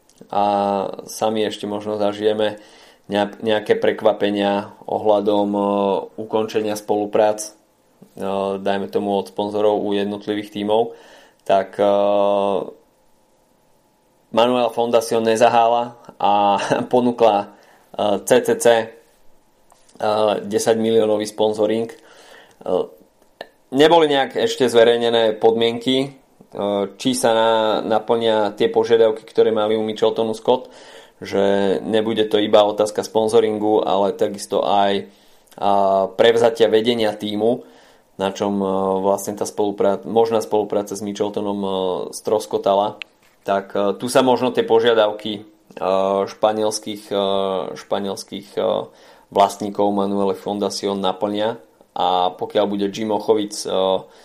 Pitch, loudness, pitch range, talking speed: 105 Hz, -19 LUFS, 100-110 Hz, 90 wpm